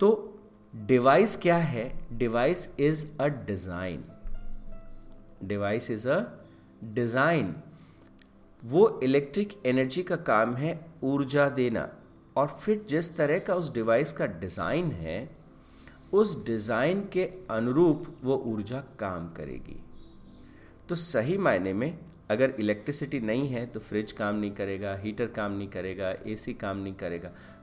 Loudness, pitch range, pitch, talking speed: -28 LUFS, 100-150 Hz, 115 Hz, 130 wpm